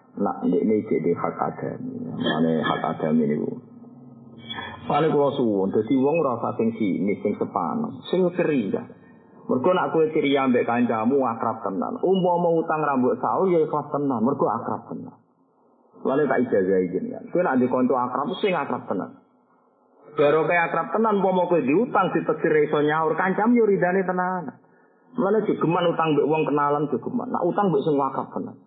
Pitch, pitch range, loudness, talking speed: 160 Hz, 140-185 Hz, -23 LUFS, 165 wpm